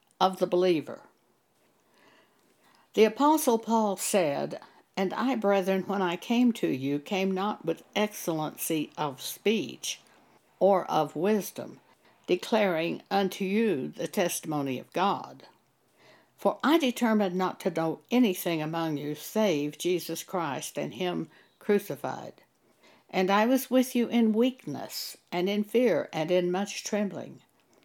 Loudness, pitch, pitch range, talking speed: -28 LUFS, 190 Hz, 170-220 Hz, 130 wpm